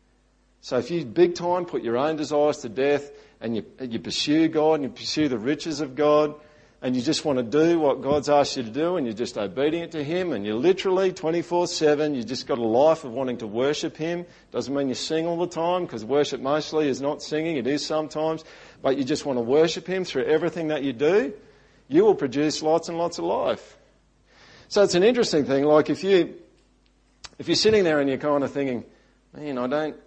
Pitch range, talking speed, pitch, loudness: 140-165 Hz, 225 wpm, 150 Hz, -24 LUFS